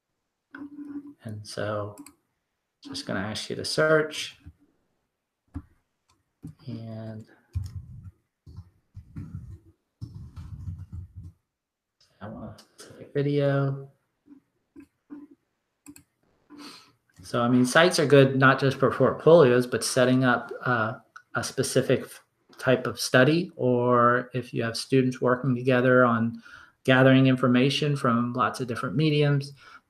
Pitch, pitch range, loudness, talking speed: 125 Hz, 115-140 Hz, -23 LUFS, 100 wpm